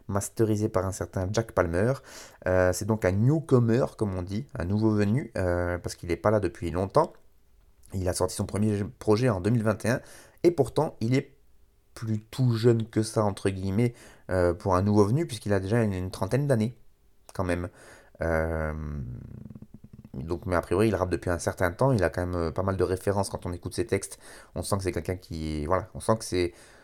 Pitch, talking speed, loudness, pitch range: 100 Hz, 205 wpm, -27 LUFS, 90-115 Hz